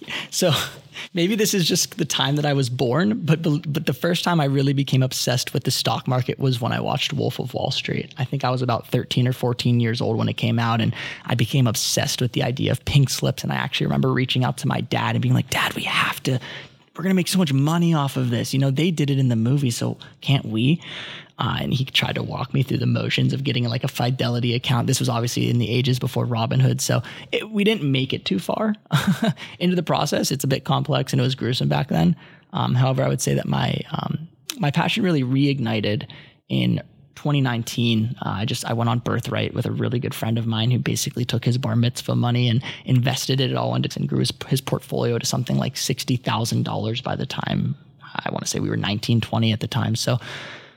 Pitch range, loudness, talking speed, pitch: 120-150 Hz, -22 LUFS, 240 wpm, 130 Hz